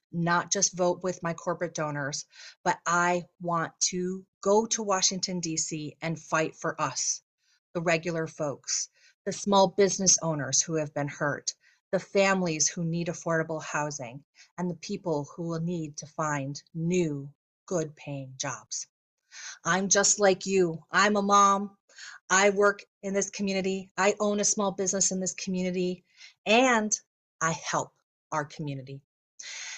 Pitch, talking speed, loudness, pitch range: 175 Hz, 145 wpm, -27 LUFS, 160-195 Hz